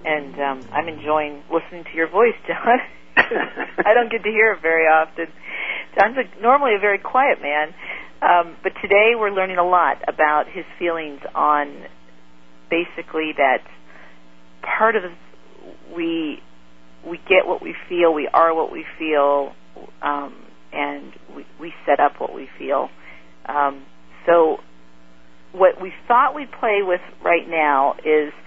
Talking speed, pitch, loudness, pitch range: 150 wpm, 160 Hz, -19 LUFS, 115-190 Hz